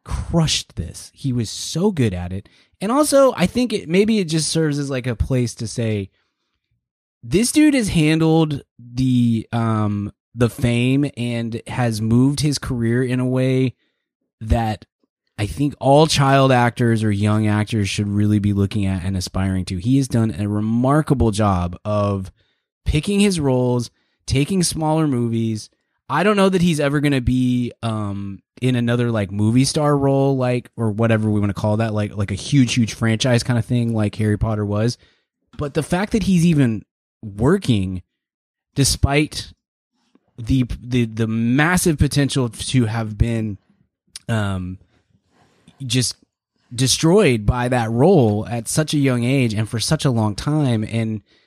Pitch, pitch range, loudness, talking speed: 120 Hz, 105-140 Hz, -19 LUFS, 160 wpm